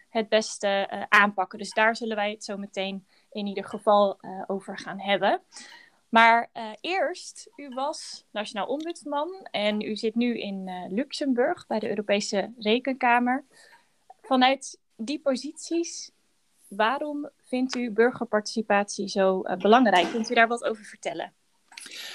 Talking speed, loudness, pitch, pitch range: 140 wpm, -26 LUFS, 225 Hz, 205-275 Hz